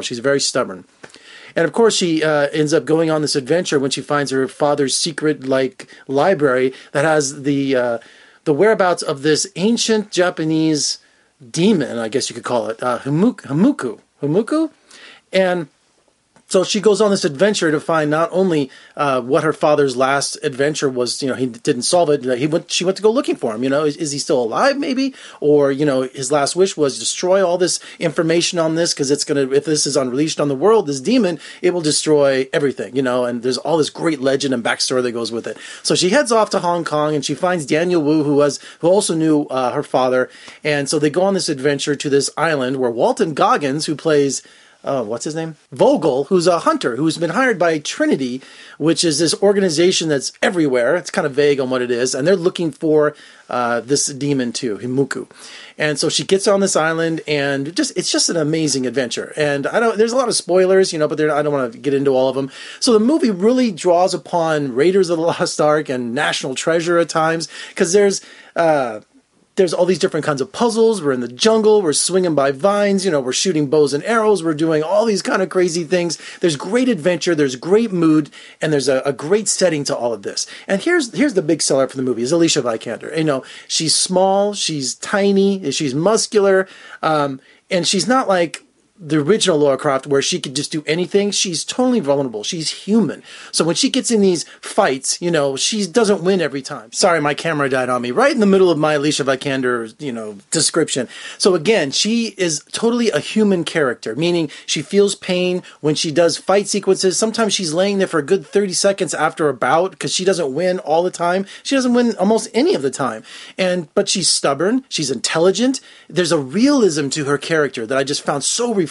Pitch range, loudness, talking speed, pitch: 145-190 Hz, -17 LUFS, 220 wpm, 160 Hz